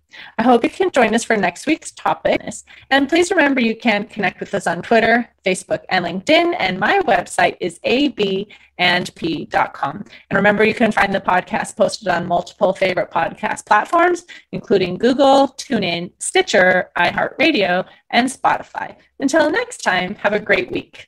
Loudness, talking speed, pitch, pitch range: -17 LUFS, 155 wpm, 215 Hz, 185-275 Hz